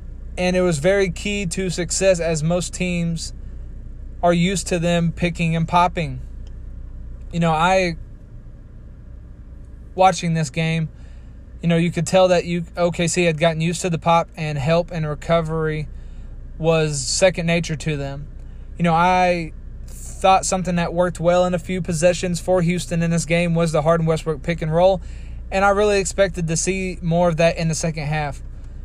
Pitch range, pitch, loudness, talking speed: 160-180 Hz, 170 Hz, -20 LUFS, 175 wpm